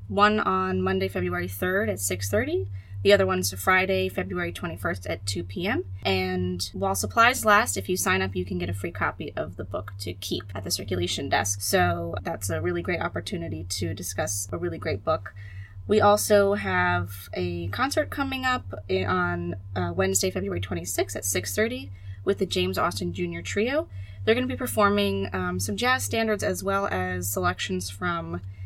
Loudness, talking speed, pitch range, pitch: -26 LUFS, 180 wpm, 90-105 Hz, 95 Hz